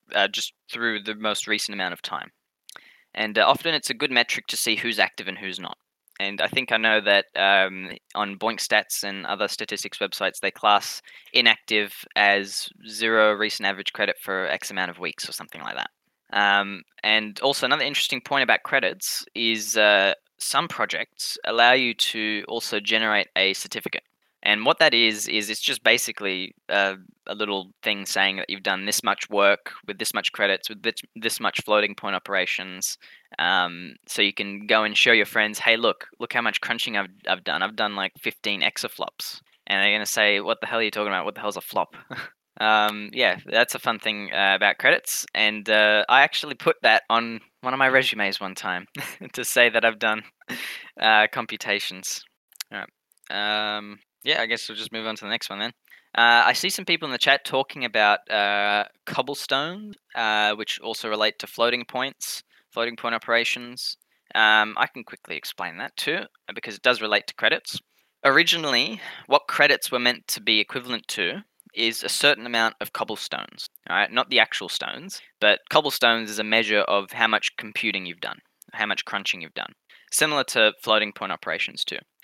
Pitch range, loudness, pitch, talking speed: 105-115 Hz, -22 LUFS, 110 Hz, 195 wpm